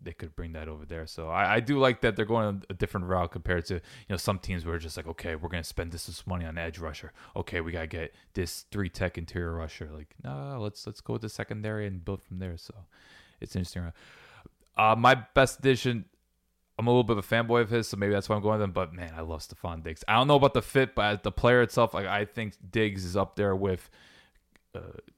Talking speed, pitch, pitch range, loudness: 255 wpm, 95 Hz, 85-110 Hz, -29 LUFS